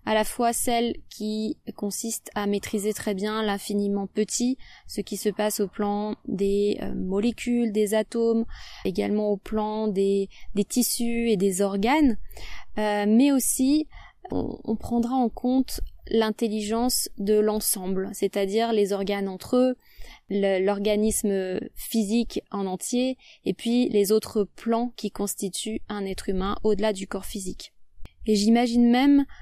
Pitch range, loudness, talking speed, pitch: 205-235 Hz, -25 LUFS, 145 wpm, 215 Hz